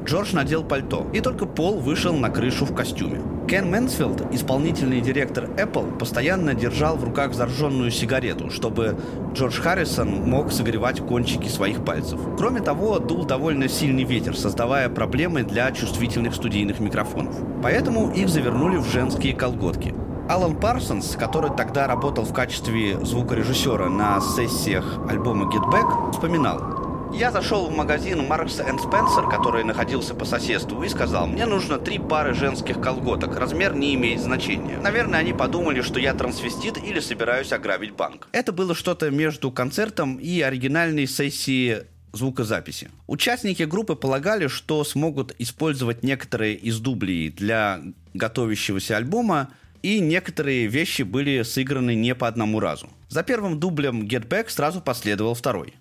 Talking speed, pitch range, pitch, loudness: 140 wpm, 115-155 Hz, 130 Hz, -23 LUFS